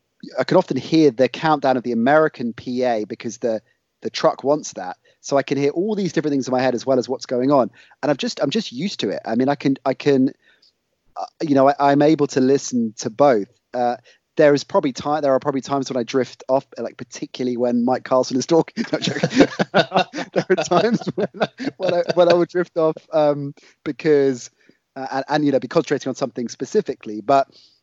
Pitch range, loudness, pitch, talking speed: 130-165 Hz, -20 LUFS, 140 Hz, 220 wpm